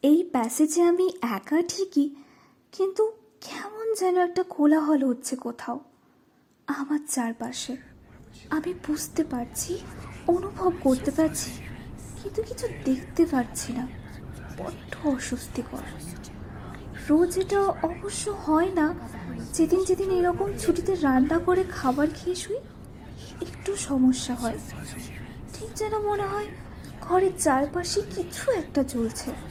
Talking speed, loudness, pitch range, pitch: 110 wpm, -26 LUFS, 270-370 Hz, 325 Hz